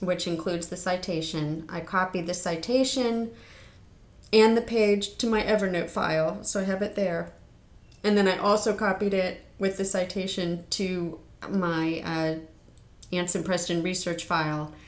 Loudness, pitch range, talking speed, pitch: -27 LUFS, 160-200 Hz, 145 wpm, 180 Hz